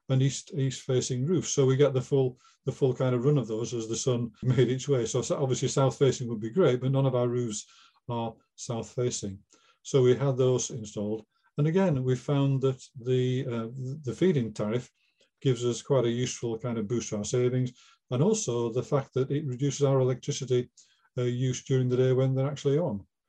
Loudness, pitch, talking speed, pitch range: -28 LUFS, 130 Hz, 210 wpm, 120-135 Hz